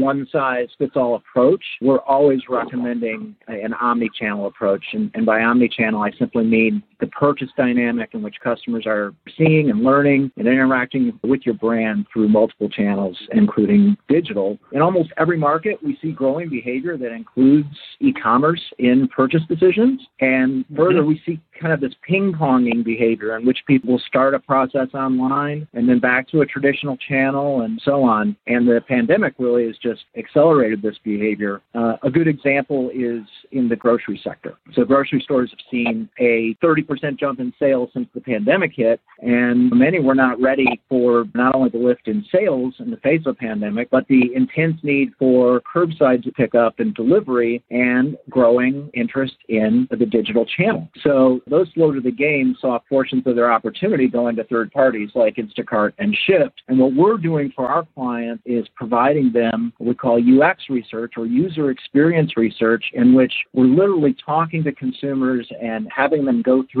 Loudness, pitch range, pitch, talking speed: -18 LUFS, 120-145 Hz, 130 Hz, 180 wpm